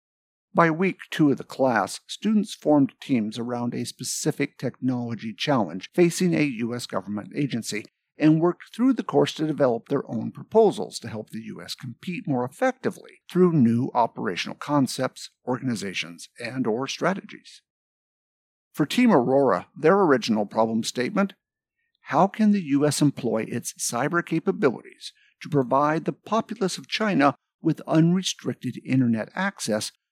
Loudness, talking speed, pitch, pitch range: -24 LUFS, 135 wpm, 145 Hz, 120-190 Hz